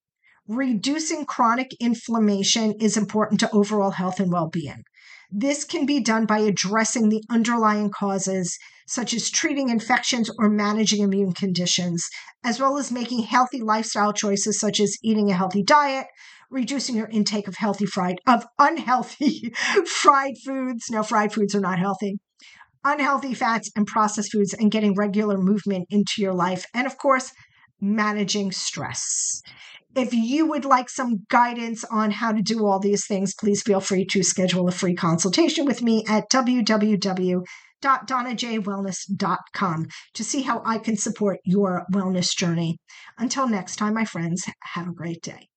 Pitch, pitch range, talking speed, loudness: 215 Hz, 195-245 Hz, 155 wpm, -22 LUFS